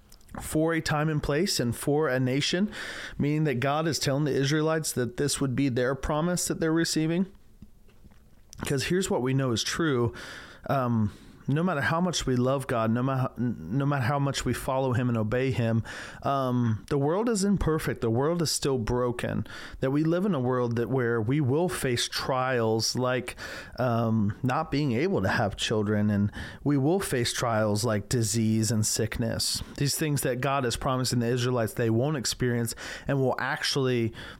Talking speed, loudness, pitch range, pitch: 185 wpm, -27 LUFS, 115-145 Hz, 130 Hz